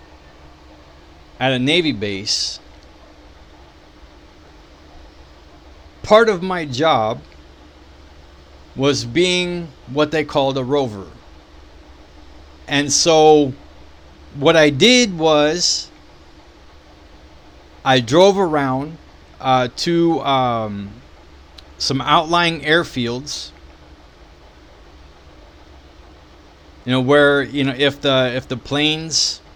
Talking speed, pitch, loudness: 80 wpm, 80 Hz, -16 LUFS